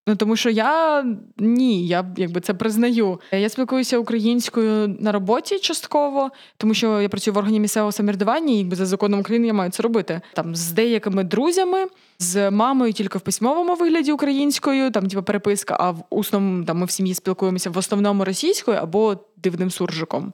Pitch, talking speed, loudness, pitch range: 210 Hz, 175 wpm, -20 LUFS, 195-240 Hz